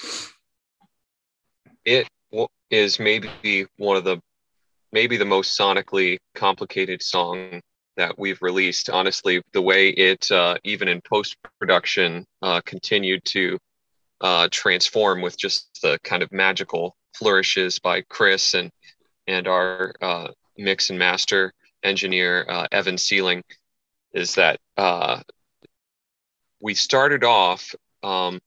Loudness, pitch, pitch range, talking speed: -20 LUFS, 95 Hz, 90-95 Hz, 120 wpm